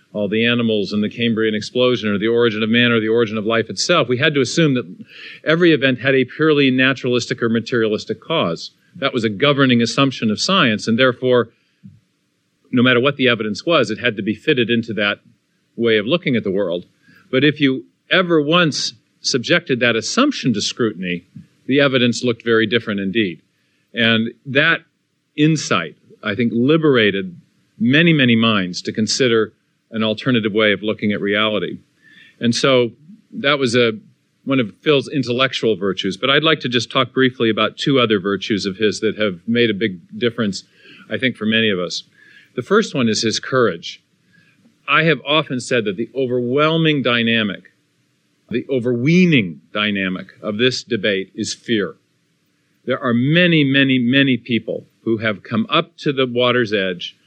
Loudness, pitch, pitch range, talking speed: -17 LUFS, 120 Hz, 110-135 Hz, 175 wpm